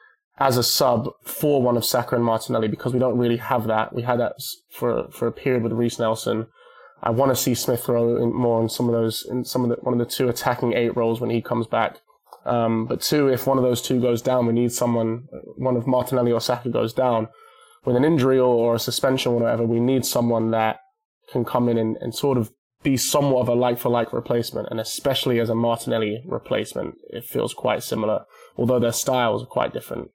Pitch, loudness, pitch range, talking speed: 120 Hz, -22 LUFS, 115-130 Hz, 225 wpm